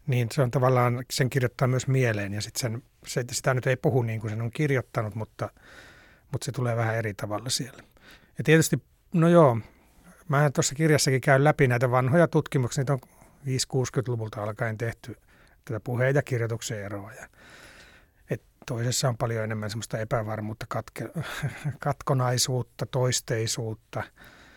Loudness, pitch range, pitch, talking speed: -26 LUFS, 115-140 Hz, 125 Hz, 145 wpm